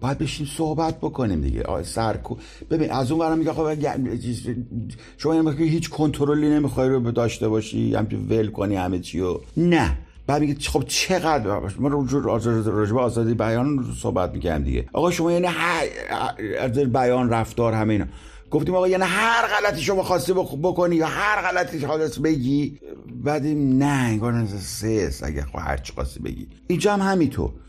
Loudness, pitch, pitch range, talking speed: -22 LUFS, 135 Hz, 110-160 Hz, 170 wpm